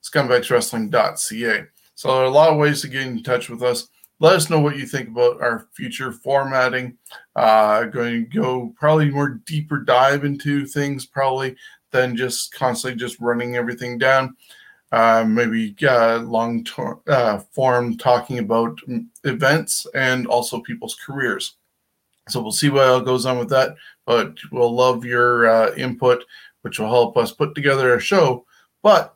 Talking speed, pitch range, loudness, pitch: 165 wpm, 120-140 Hz, -19 LUFS, 125 Hz